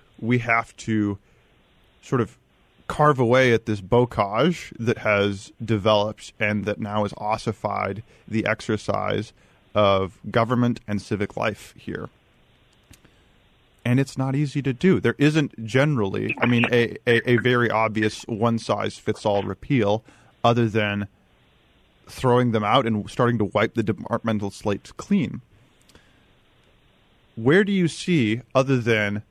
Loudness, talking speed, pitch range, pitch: -22 LUFS, 130 wpm, 105-125 Hz, 115 Hz